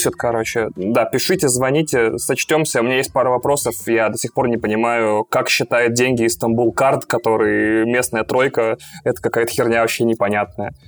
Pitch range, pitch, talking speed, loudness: 110-125 Hz, 115 Hz, 160 wpm, -17 LUFS